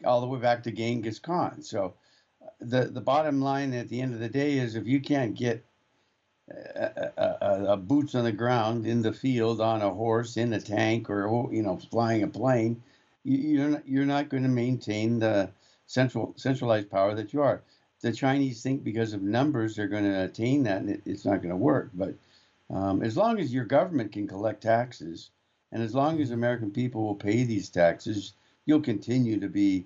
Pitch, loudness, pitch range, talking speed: 120 Hz, -28 LUFS, 110-135 Hz, 205 wpm